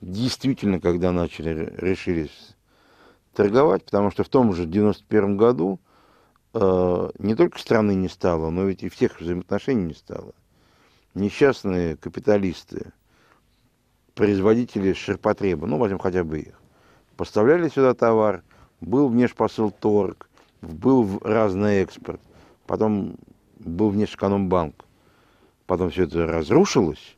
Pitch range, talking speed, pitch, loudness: 90-110 Hz, 115 wpm, 100 Hz, -22 LUFS